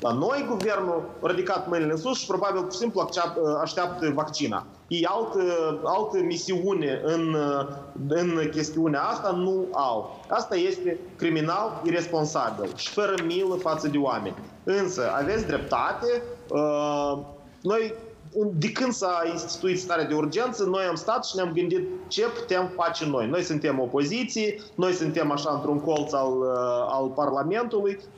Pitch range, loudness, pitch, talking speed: 155-195 Hz, -26 LUFS, 170 Hz, 140 wpm